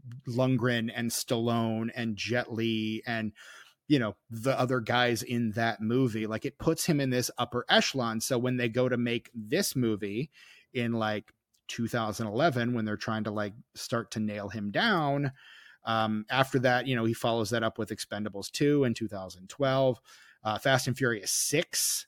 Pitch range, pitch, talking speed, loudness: 110-125 Hz, 115 Hz, 170 wpm, -29 LUFS